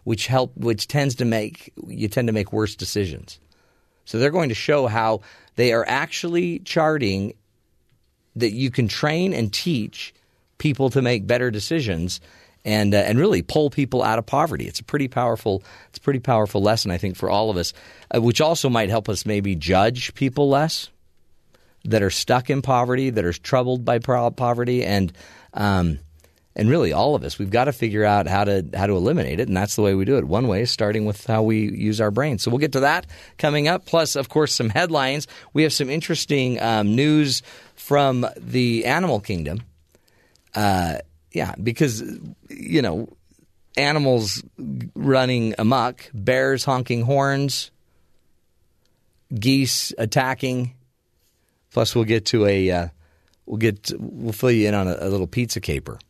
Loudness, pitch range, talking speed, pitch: -21 LUFS, 100-130 Hz, 175 wpm, 115 Hz